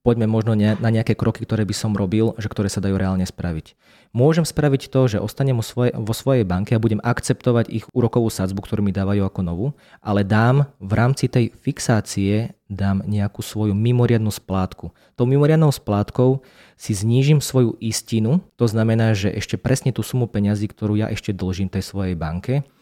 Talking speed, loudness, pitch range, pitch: 175 wpm, -20 LUFS, 105-125 Hz, 110 Hz